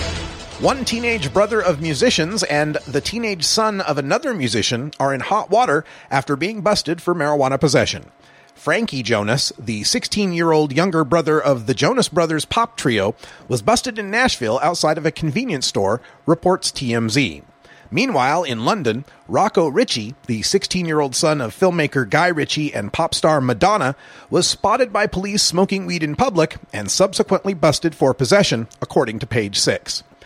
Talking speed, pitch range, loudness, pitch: 155 wpm, 135-190 Hz, -18 LUFS, 155 Hz